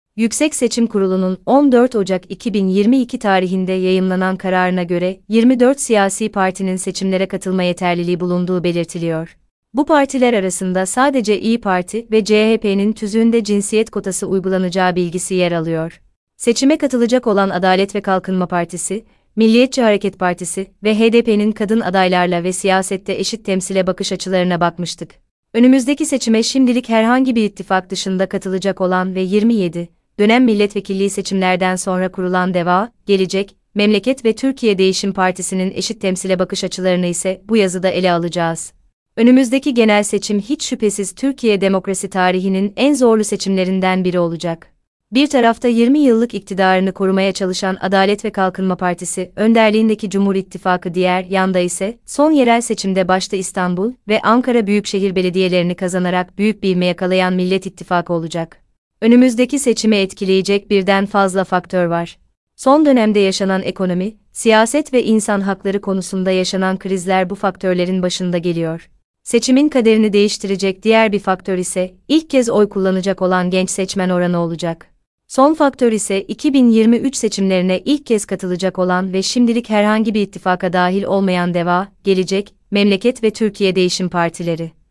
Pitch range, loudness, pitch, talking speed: 185-220 Hz, -16 LUFS, 195 Hz, 135 wpm